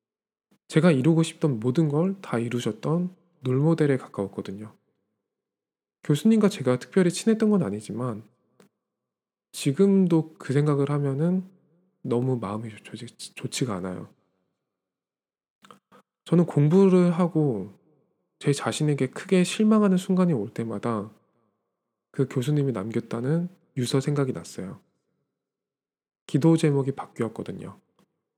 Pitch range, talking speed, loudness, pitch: 120-175 Hz, 250 characters per minute, -24 LUFS, 145 Hz